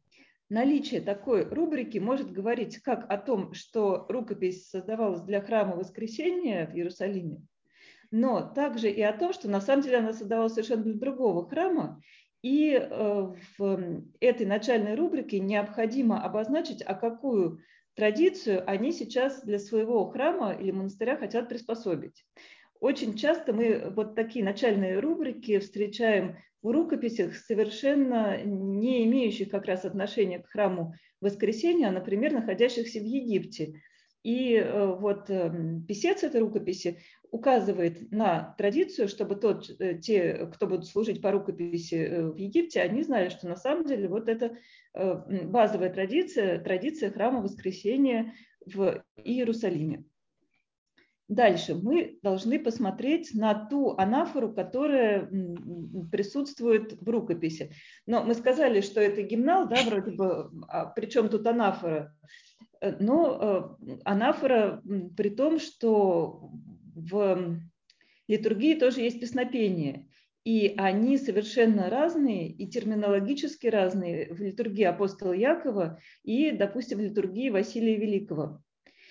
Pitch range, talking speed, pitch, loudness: 195-245 Hz, 120 wpm, 215 Hz, -28 LUFS